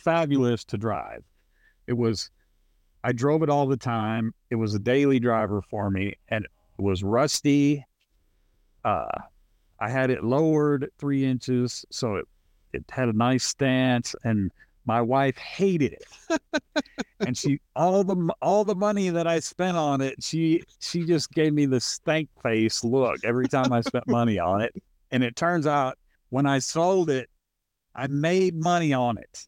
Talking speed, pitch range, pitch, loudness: 165 wpm, 115-155 Hz, 130 Hz, -25 LUFS